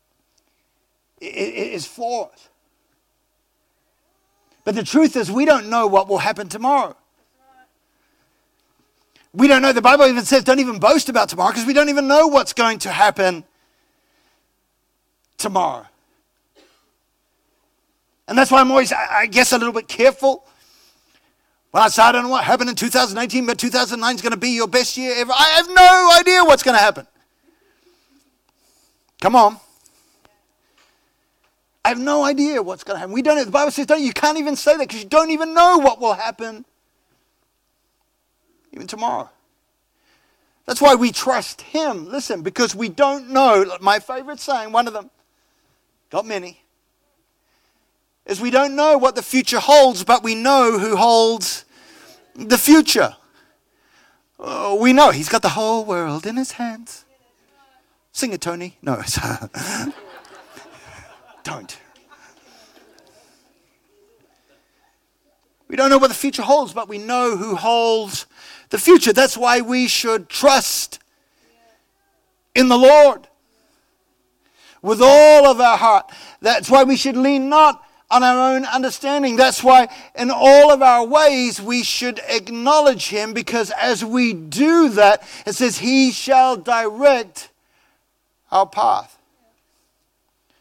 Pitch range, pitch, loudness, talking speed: 230-290 Hz, 260 Hz, -15 LUFS, 145 wpm